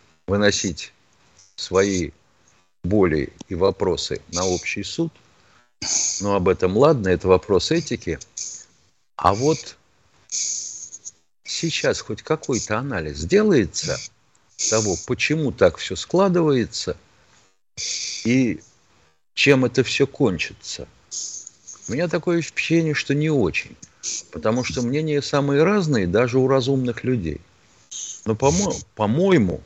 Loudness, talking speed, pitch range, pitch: -21 LUFS, 105 wpm, 95-140 Hz, 115 Hz